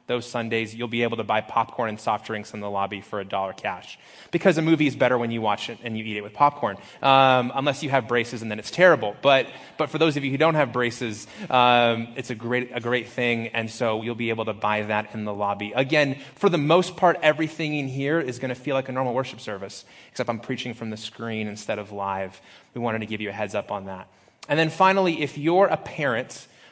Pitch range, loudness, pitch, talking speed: 110-140 Hz, -24 LUFS, 120 Hz, 255 wpm